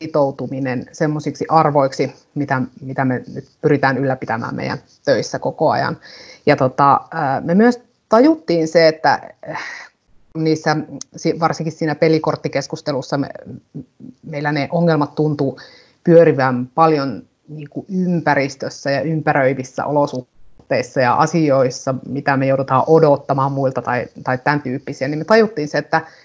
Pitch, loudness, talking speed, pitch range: 145 Hz, -17 LUFS, 120 wpm, 135-160 Hz